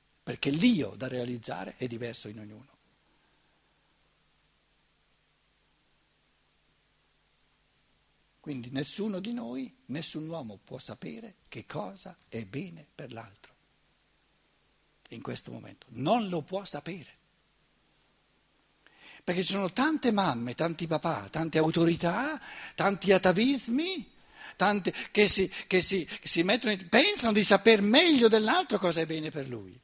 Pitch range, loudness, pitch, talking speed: 155-225 Hz, -26 LUFS, 185 Hz, 115 wpm